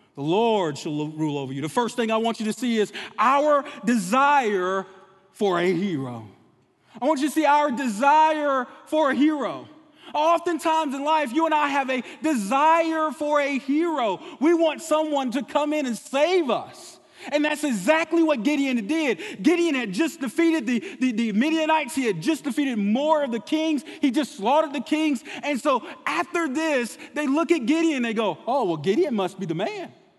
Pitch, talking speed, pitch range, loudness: 285 Hz, 190 wpm, 230-310 Hz, -23 LUFS